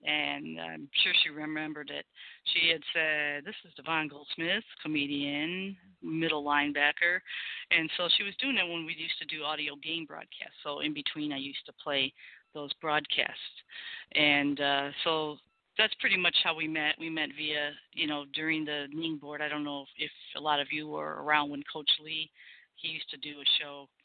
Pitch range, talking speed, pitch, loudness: 145-165 Hz, 190 wpm, 150 Hz, -30 LUFS